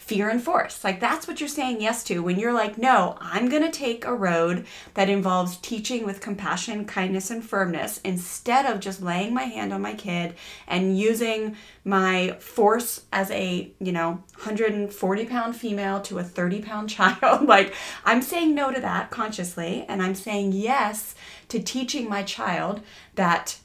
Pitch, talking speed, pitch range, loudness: 205 Hz, 175 wpm, 185-235 Hz, -24 LUFS